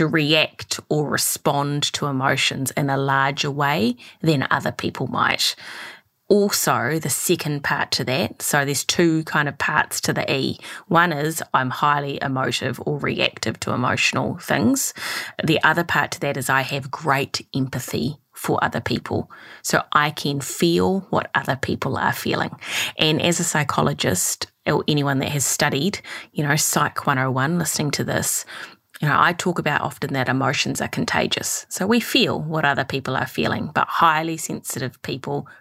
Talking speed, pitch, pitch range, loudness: 165 wpm, 145 Hz, 135-160 Hz, -21 LUFS